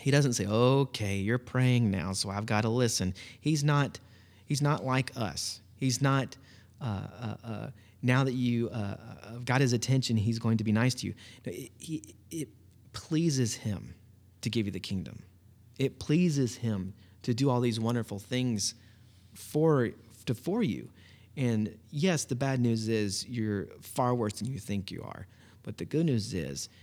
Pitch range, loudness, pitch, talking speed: 105-130 Hz, -31 LUFS, 115 Hz, 180 wpm